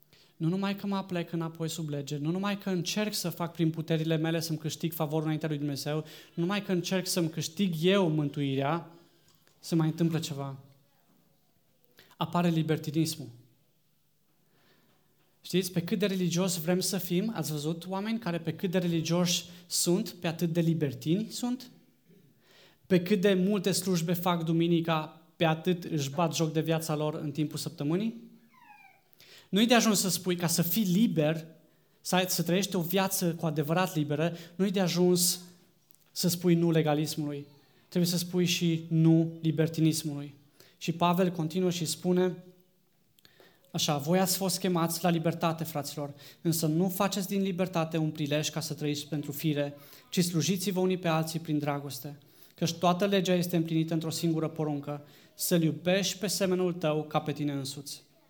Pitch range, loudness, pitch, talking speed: 155-180 Hz, -29 LUFS, 170 Hz, 160 wpm